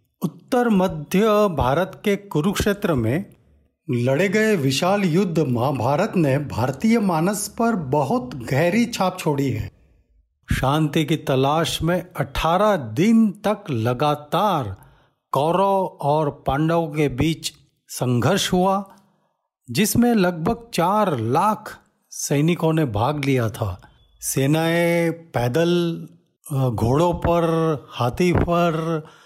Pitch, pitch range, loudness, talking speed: 160 Hz, 135-185 Hz, -21 LUFS, 105 wpm